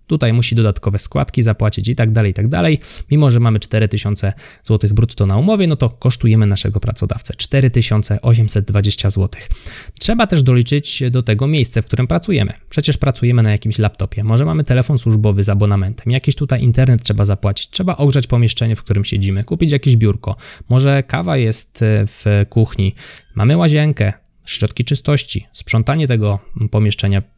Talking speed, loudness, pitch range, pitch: 160 wpm, -15 LUFS, 105-130 Hz, 115 Hz